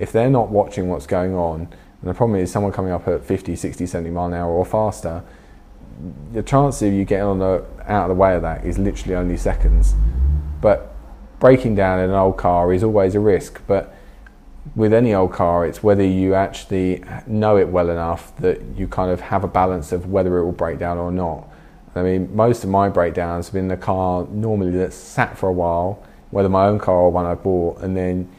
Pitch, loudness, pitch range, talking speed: 90 Hz, -19 LUFS, 85-100 Hz, 220 wpm